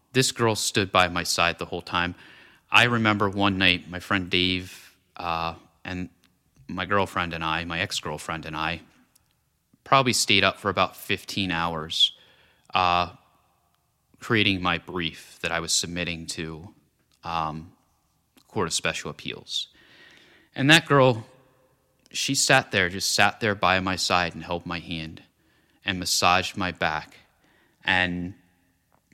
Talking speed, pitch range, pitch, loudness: 140 wpm, 85-100 Hz, 90 Hz, -24 LUFS